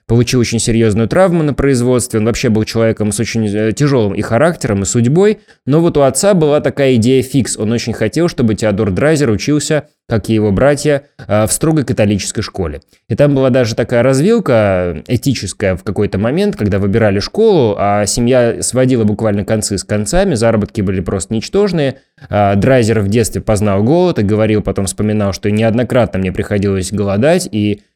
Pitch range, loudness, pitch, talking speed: 105-135 Hz, -13 LUFS, 115 Hz, 170 wpm